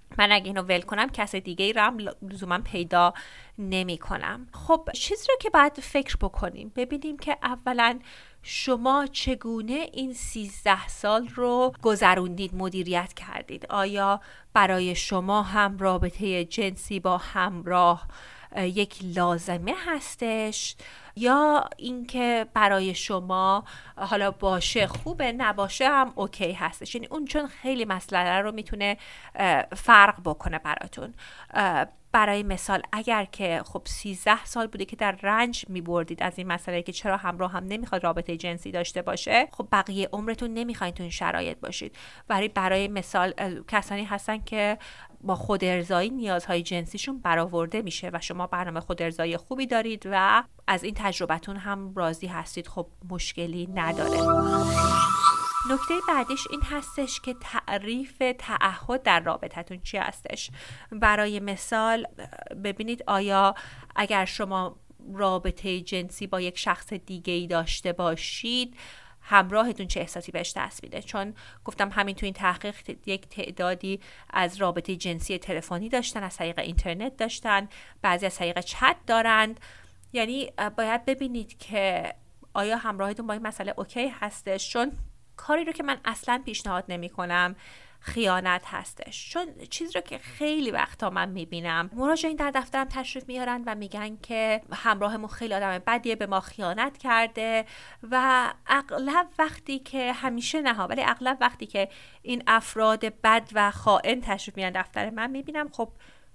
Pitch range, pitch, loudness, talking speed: 185-235 Hz, 205 Hz, -26 LUFS, 140 wpm